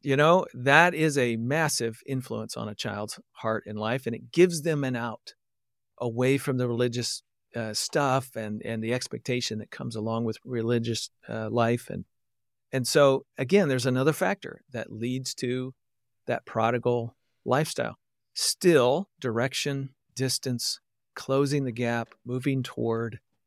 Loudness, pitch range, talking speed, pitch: -27 LUFS, 115-135 Hz, 145 wpm, 120 Hz